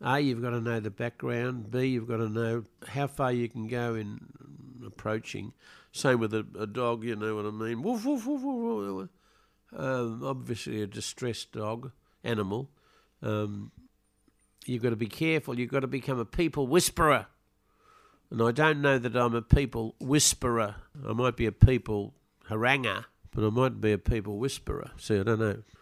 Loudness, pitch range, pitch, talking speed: -30 LUFS, 110-130 Hz, 120 Hz, 185 wpm